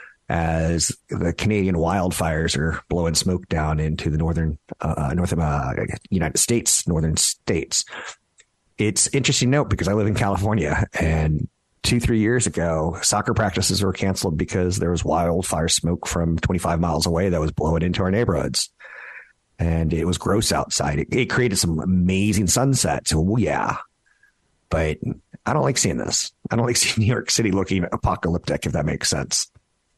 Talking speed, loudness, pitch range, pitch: 170 wpm, -21 LUFS, 80-105 Hz, 90 Hz